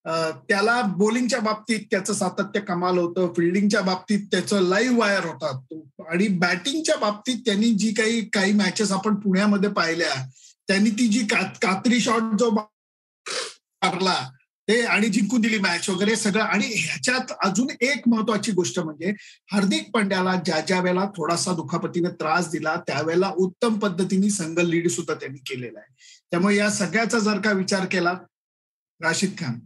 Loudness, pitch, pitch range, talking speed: -22 LUFS, 200 Hz, 175-220 Hz, 145 wpm